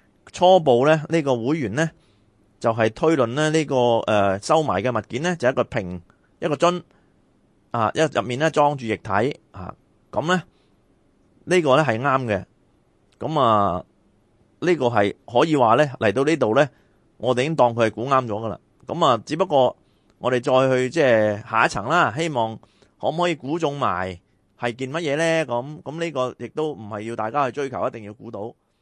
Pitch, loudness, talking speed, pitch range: 125 Hz, -21 LUFS, 265 characters per minute, 110-155 Hz